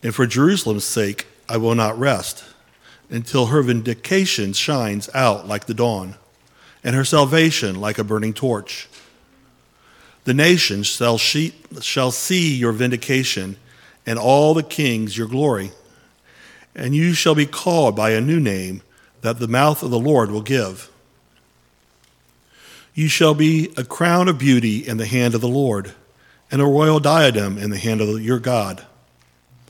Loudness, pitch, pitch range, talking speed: -18 LUFS, 120 Hz, 105-145 Hz, 150 wpm